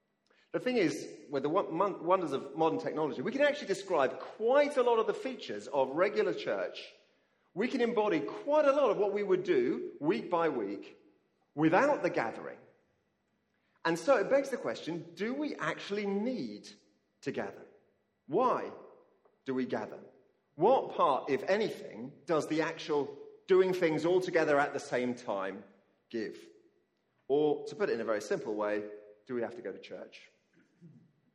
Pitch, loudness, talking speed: 215 Hz, -32 LUFS, 165 wpm